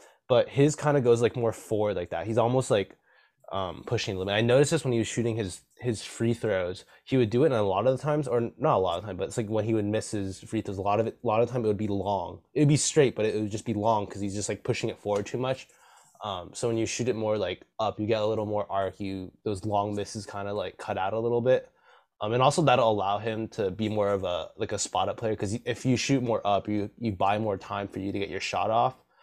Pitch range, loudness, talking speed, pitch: 100-120 Hz, -28 LUFS, 305 wpm, 110 Hz